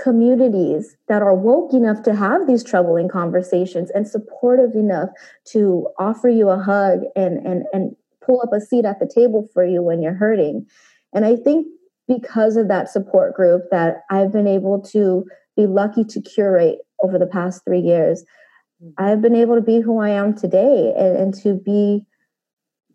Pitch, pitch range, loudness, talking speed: 205 Hz, 190-235 Hz, -17 LUFS, 180 wpm